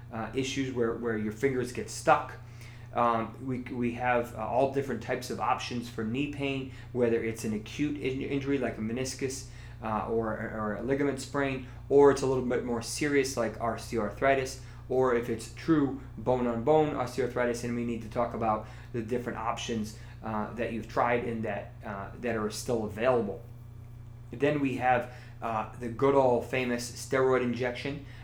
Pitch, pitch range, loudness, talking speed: 120 Hz, 115-130 Hz, -30 LUFS, 180 wpm